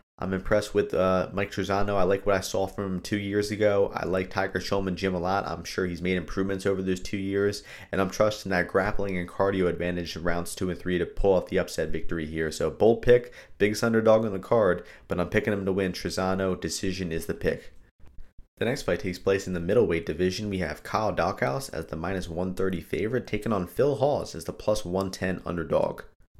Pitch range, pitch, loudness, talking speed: 90-100 Hz, 95 Hz, -27 LUFS, 225 wpm